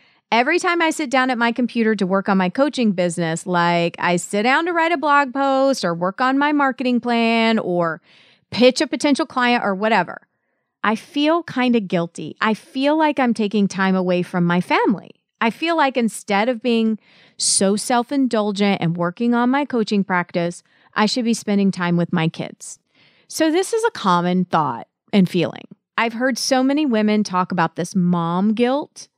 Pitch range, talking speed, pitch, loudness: 180-260 Hz, 190 wpm, 220 Hz, -19 LUFS